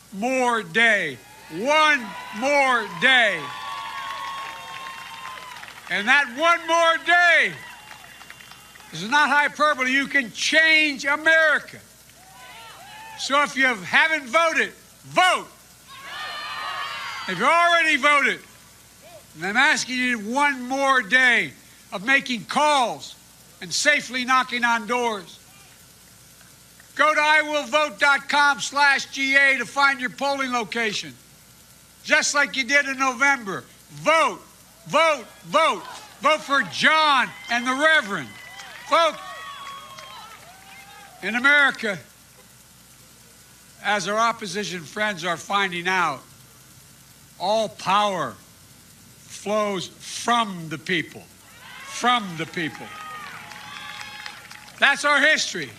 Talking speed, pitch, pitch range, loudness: 95 wpm, 260 Hz, 205-295 Hz, -20 LUFS